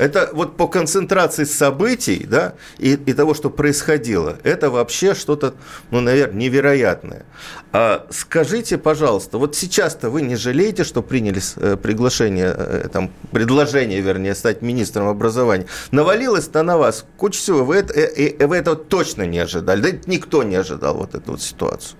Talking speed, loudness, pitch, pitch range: 155 wpm, -18 LUFS, 140 Hz, 115-160 Hz